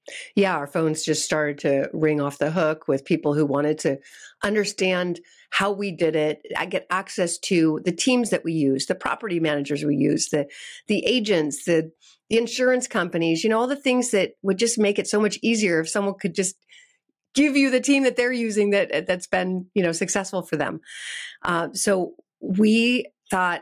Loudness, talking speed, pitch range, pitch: -23 LUFS, 195 wpm, 160-215 Hz, 185 Hz